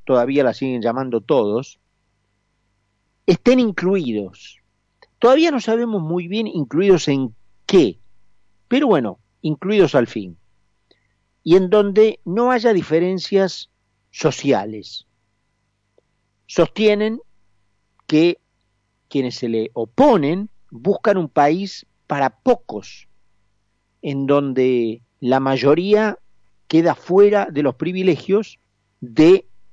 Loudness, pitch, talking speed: -18 LUFS, 135 Hz, 95 wpm